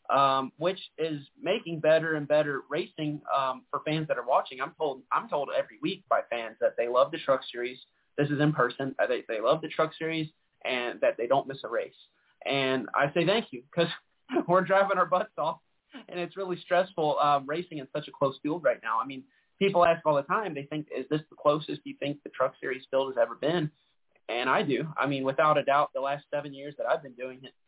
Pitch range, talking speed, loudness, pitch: 135-170 Hz, 235 wpm, -29 LUFS, 150 Hz